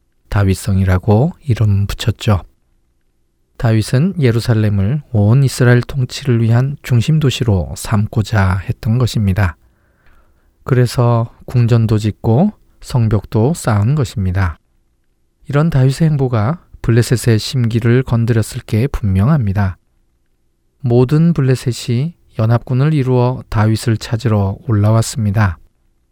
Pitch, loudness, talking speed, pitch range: 115 Hz, -15 LUFS, 255 characters per minute, 100-125 Hz